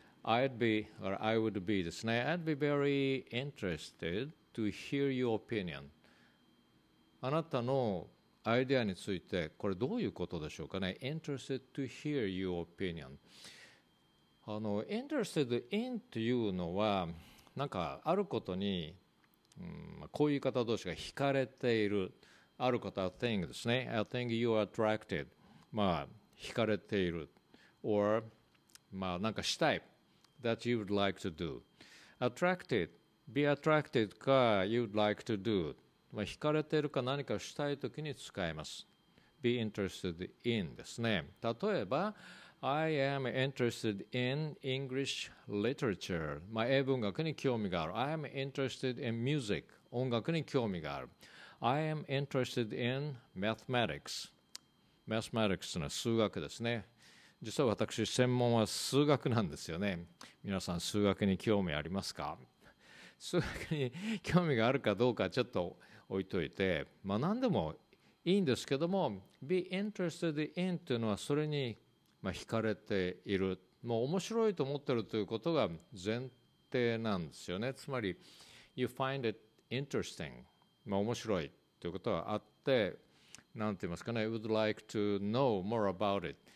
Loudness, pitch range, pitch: -36 LUFS, 100-135 Hz, 115 Hz